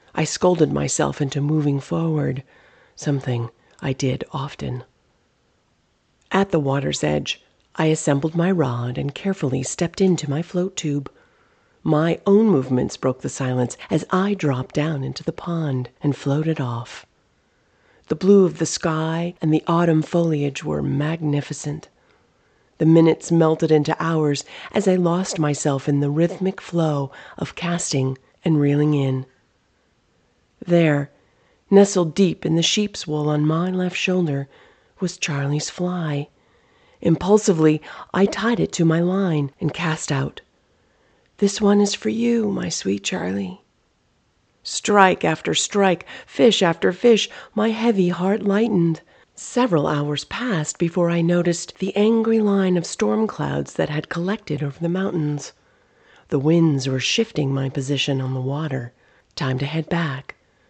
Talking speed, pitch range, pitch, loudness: 140 wpm, 145-185 Hz, 160 Hz, -21 LUFS